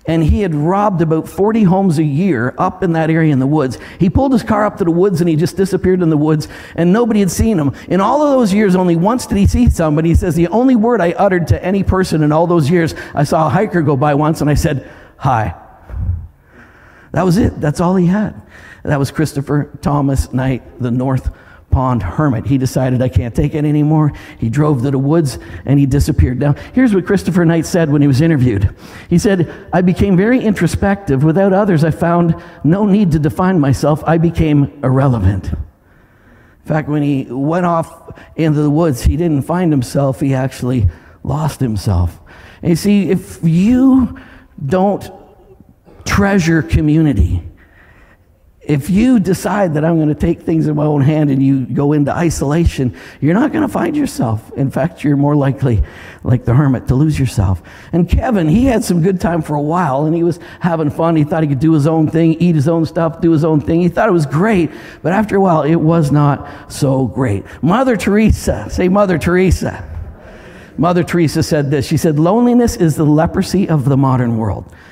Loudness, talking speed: -14 LUFS, 200 wpm